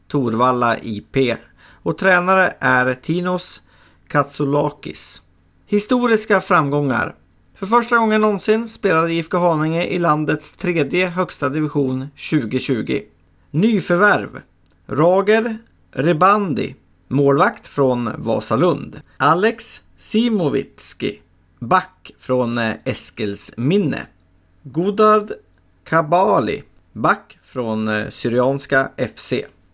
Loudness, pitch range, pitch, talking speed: -18 LUFS, 120-185 Hz, 145 Hz, 80 wpm